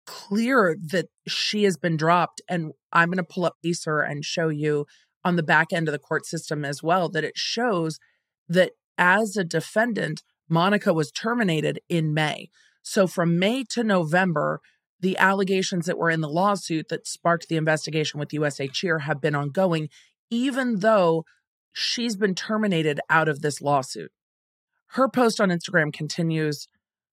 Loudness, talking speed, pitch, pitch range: -24 LUFS, 165 wpm, 170 Hz, 155-195 Hz